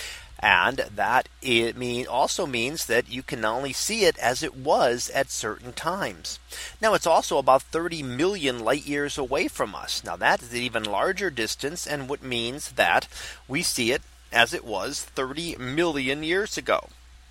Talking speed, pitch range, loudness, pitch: 175 wpm, 120-150 Hz, -25 LUFS, 130 Hz